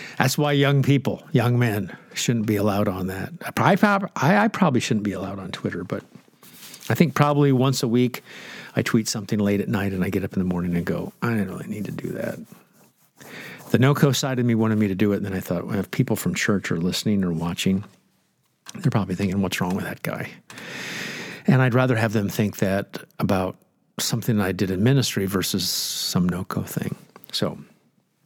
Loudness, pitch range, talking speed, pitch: -23 LUFS, 95-130 Hz, 210 wpm, 110 Hz